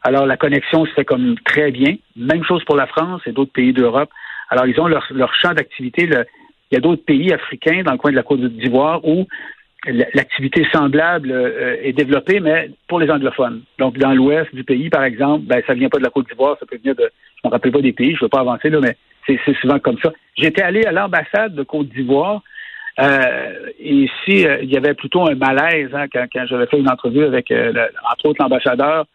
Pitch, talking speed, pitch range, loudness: 150 Hz, 240 wpm, 135-170 Hz, -16 LUFS